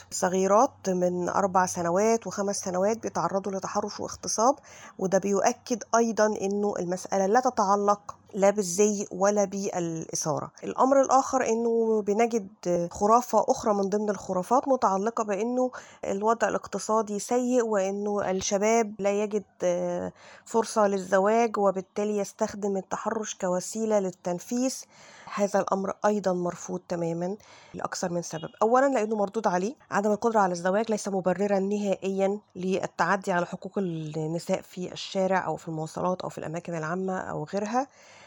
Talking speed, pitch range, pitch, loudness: 125 wpm, 185-220 Hz, 200 Hz, -27 LUFS